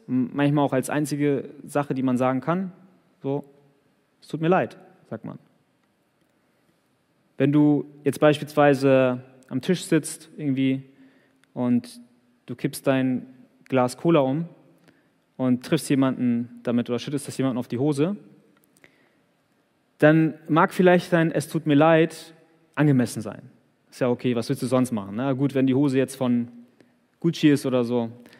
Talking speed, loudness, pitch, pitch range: 150 wpm, -23 LUFS, 140 Hz, 125-150 Hz